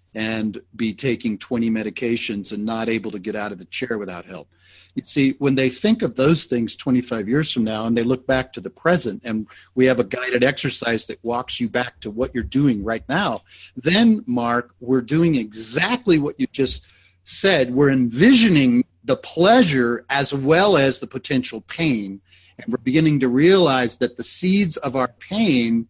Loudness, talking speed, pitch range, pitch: -20 LUFS, 190 wpm, 115-140 Hz, 125 Hz